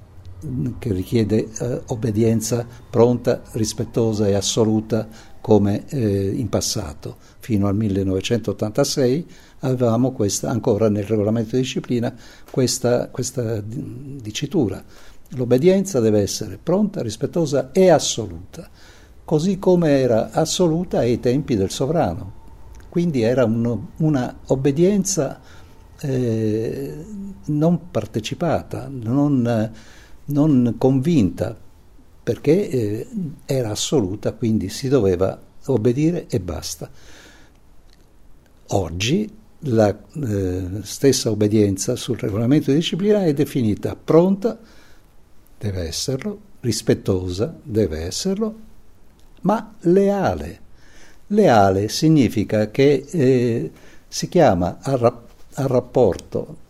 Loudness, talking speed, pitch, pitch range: -20 LUFS, 95 wpm, 120 Hz, 105-140 Hz